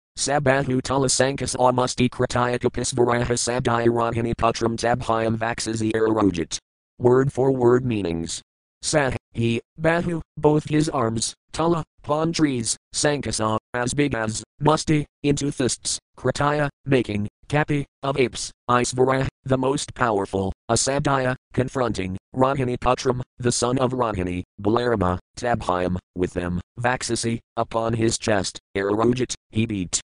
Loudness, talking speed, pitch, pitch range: -23 LUFS, 115 wpm, 120 Hz, 110-130 Hz